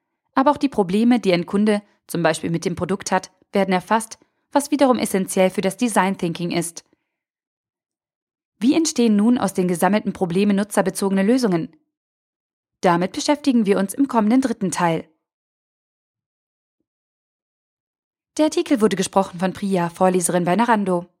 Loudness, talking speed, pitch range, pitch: -20 LUFS, 140 wpm, 185-245 Hz, 200 Hz